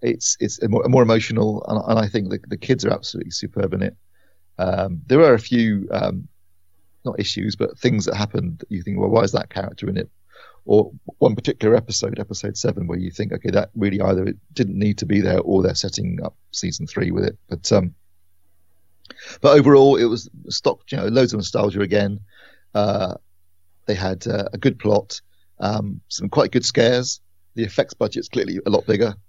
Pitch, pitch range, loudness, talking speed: 100 Hz, 90-115 Hz, -20 LUFS, 205 wpm